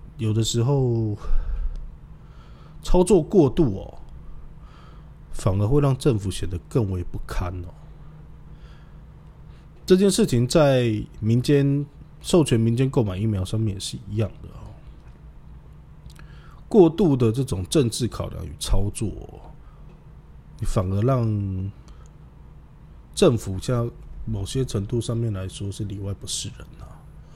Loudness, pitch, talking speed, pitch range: -23 LUFS, 110 Hz, 175 characters per minute, 100-130 Hz